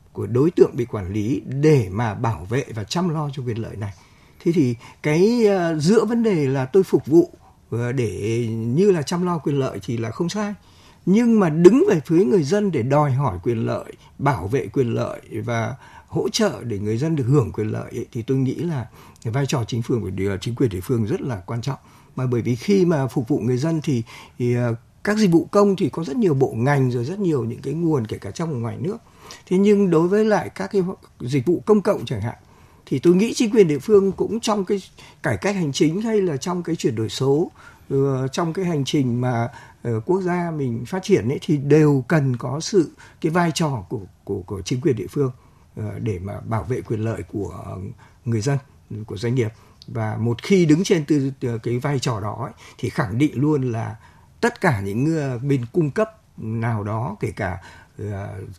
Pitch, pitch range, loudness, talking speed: 135 Hz, 115-175 Hz, -21 LUFS, 215 wpm